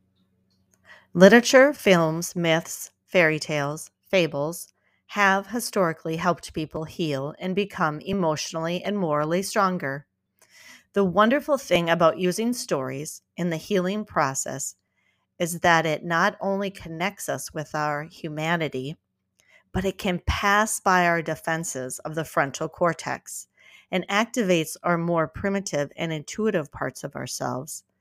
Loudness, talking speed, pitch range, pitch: -24 LUFS, 125 wpm, 150-195 Hz, 170 Hz